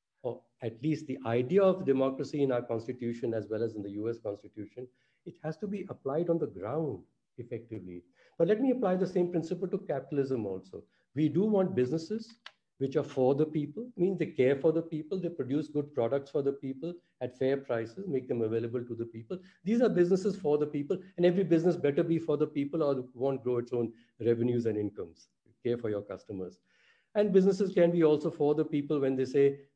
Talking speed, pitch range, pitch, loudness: 210 wpm, 120-170 Hz, 145 Hz, -31 LUFS